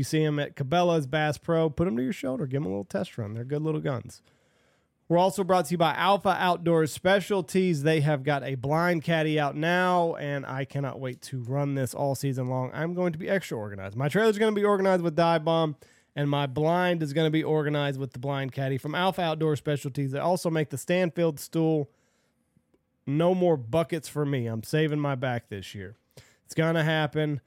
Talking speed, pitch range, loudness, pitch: 220 wpm, 140-170 Hz, -27 LUFS, 155 Hz